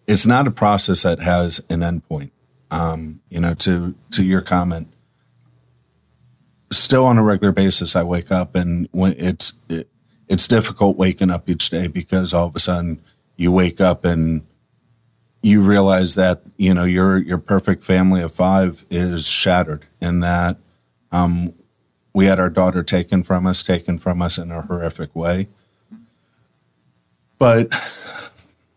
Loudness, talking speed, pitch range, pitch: -17 LUFS, 155 wpm, 85-100 Hz, 90 Hz